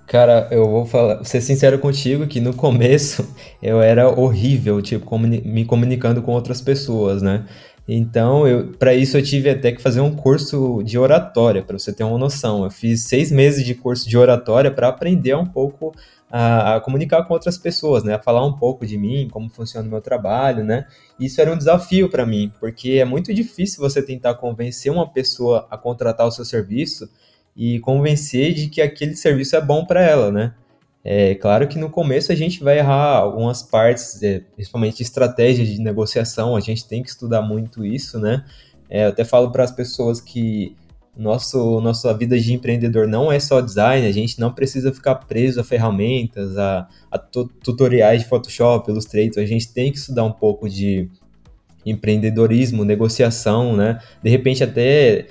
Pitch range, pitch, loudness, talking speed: 110-135 Hz, 120 Hz, -17 LUFS, 185 wpm